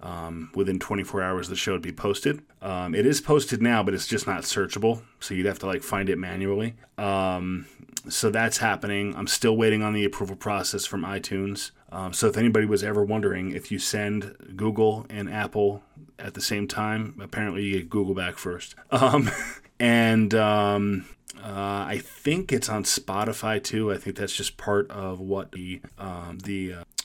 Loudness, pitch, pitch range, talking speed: -26 LUFS, 100 Hz, 95-110 Hz, 190 wpm